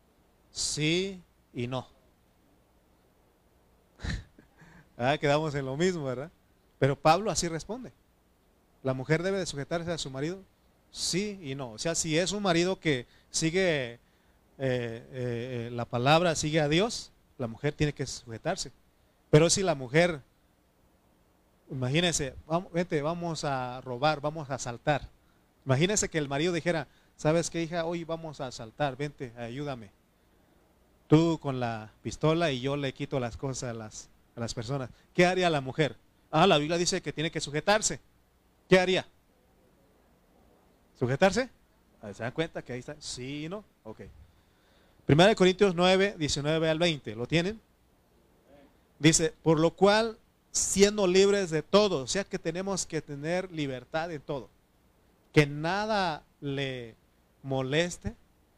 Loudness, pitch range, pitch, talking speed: -29 LUFS, 120-170 Hz, 145 Hz, 145 wpm